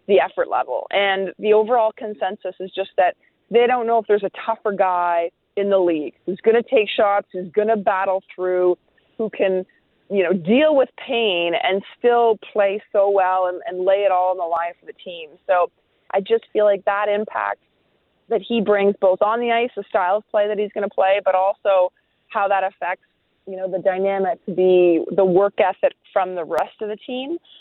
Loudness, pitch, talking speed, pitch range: -20 LUFS, 195 Hz, 210 wpm, 185-220 Hz